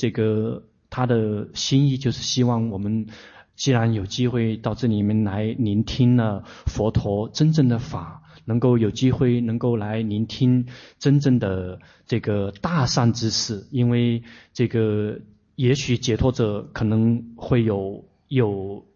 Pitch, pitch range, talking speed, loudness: 115 Hz, 110-125 Hz, 205 characters per minute, -22 LUFS